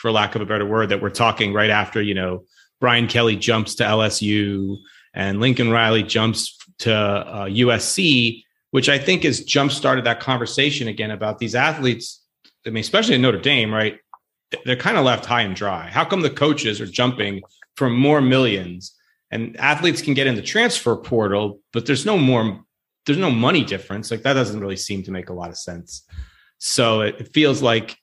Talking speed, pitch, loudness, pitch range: 195 wpm, 115 Hz, -19 LUFS, 105-125 Hz